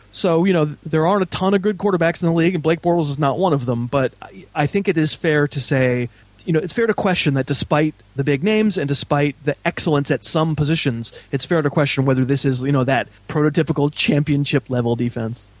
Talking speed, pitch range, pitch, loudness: 235 wpm, 135-165 Hz, 145 Hz, -19 LUFS